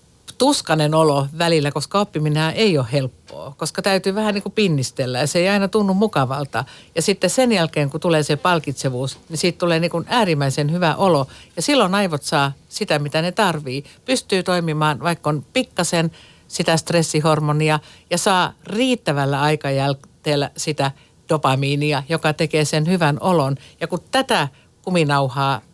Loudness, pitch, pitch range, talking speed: -19 LUFS, 160 Hz, 145-180 Hz, 155 wpm